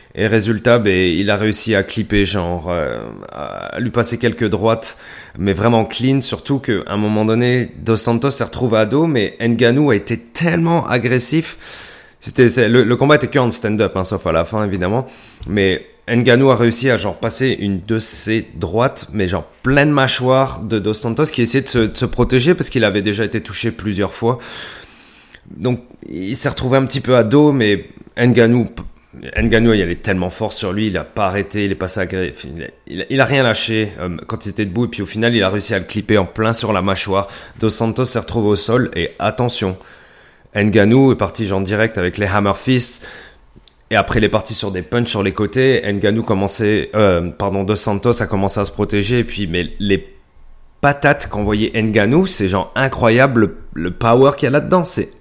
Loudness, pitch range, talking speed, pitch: -16 LUFS, 100-125 Hz, 210 wpm, 110 Hz